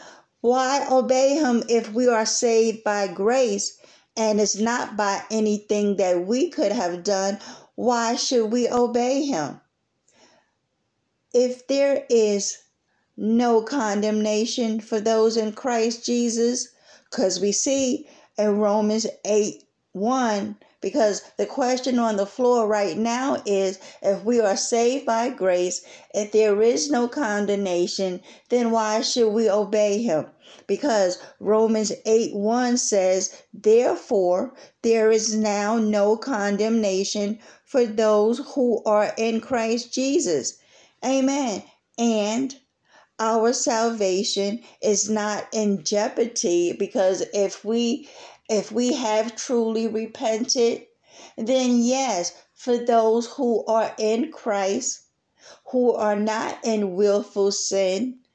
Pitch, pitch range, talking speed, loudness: 225 Hz, 210-245 Hz, 120 wpm, -22 LUFS